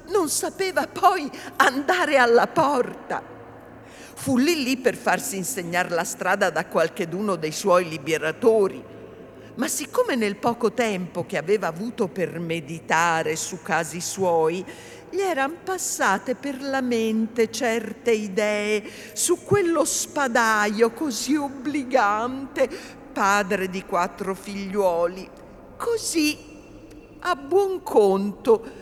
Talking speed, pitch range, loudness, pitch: 110 wpm, 185-280 Hz, -23 LUFS, 220 Hz